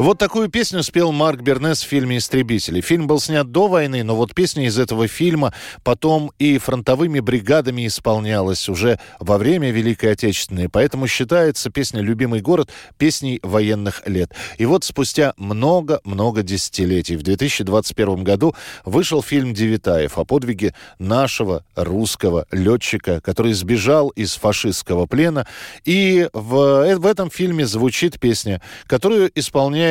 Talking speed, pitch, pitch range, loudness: 135 wpm, 125 Hz, 105-150 Hz, -18 LUFS